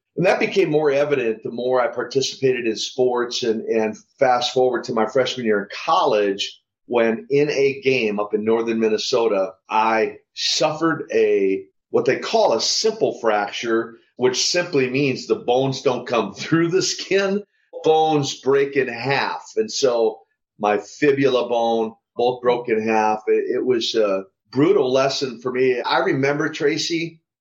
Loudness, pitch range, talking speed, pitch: -20 LUFS, 115-185 Hz, 155 wpm, 135 Hz